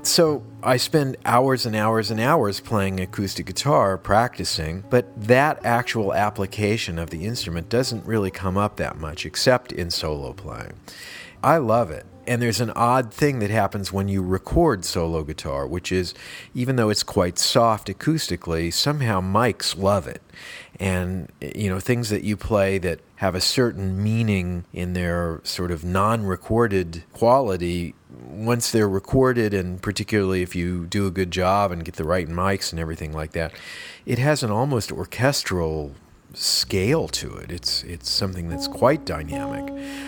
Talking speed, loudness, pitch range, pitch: 160 wpm, -22 LUFS, 90-115 Hz, 100 Hz